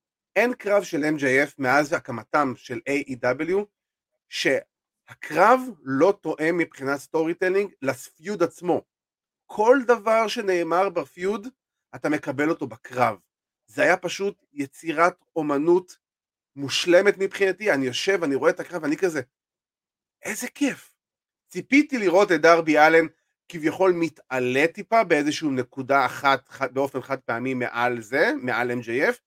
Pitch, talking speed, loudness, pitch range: 165 Hz, 120 wpm, -23 LUFS, 140-195 Hz